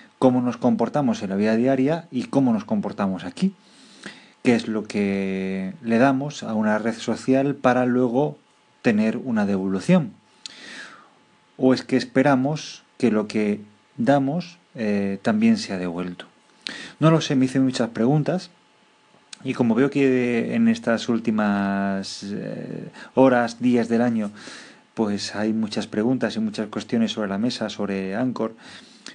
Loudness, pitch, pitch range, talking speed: -22 LUFS, 120 Hz, 105-135 Hz, 140 wpm